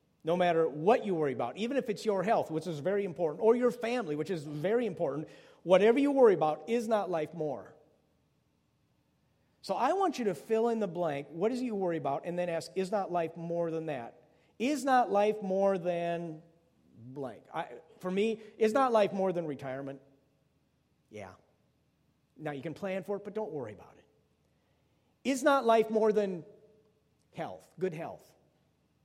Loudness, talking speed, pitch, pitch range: -31 LUFS, 185 wpm, 190 Hz, 165-220 Hz